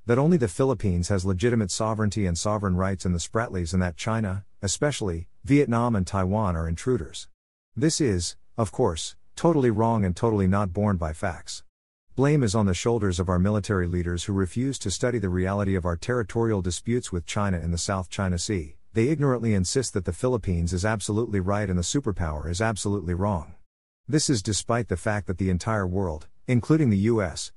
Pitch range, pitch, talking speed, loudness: 90-115 Hz, 100 Hz, 190 wpm, -25 LUFS